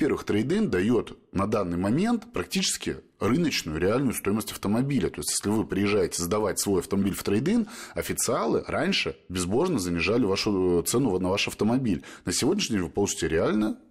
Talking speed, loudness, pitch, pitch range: 155 wpm, -26 LUFS, 100 Hz, 90-125 Hz